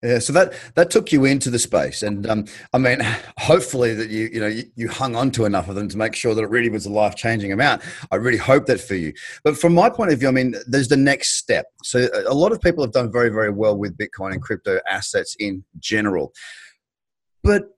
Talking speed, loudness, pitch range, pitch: 245 wpm, -19 LUFS, 110-145 Hz, 120 Hz